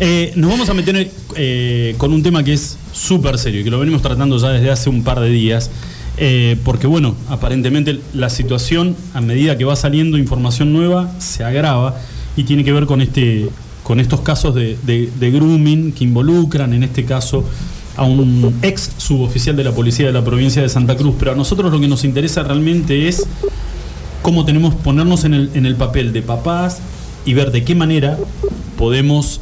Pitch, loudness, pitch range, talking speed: 140 Hz, -14 LUFS, 125-155 Hz, 195 wpm